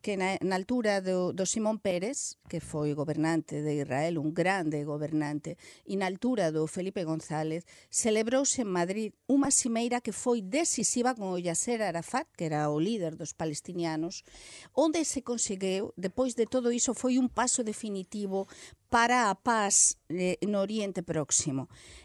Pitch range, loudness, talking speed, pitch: 165-235 Hz, -30 LUFS, 155 wpm, 190 Hz